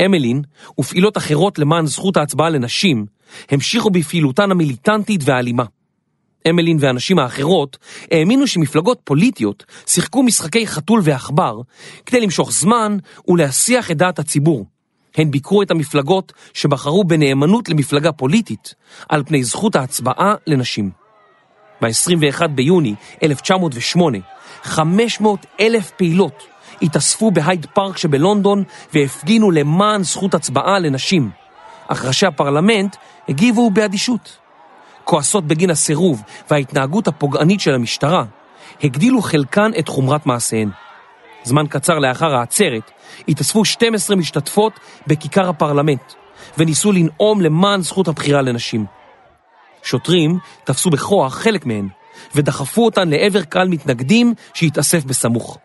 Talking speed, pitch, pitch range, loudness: 110 wpm, 165 Hz, 145-200 Hz, -16 LUFS